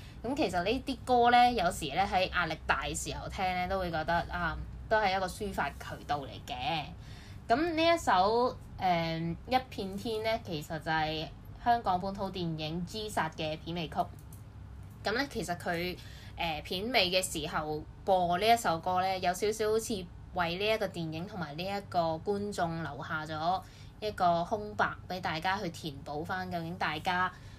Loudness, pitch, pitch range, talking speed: -32 LUFS, 180 Hz, 160-210 Hz, 250 characters per minute